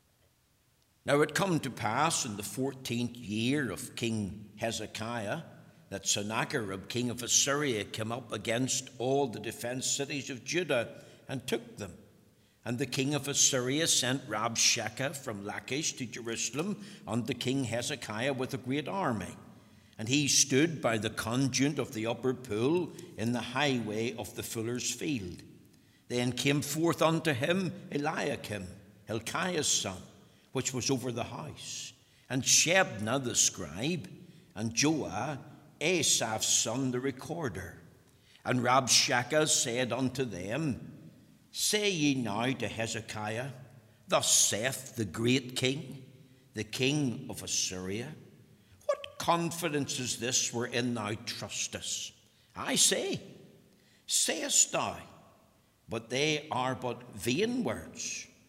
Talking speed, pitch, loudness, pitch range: 125 wpm, 125 Hz, -31 LUFS, 115-140 Hz